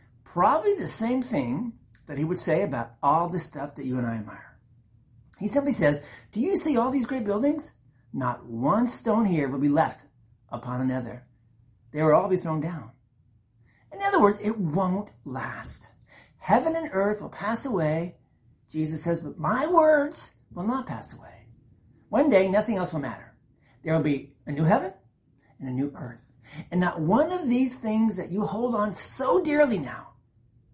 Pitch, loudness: 160 Hz, -26 LUFS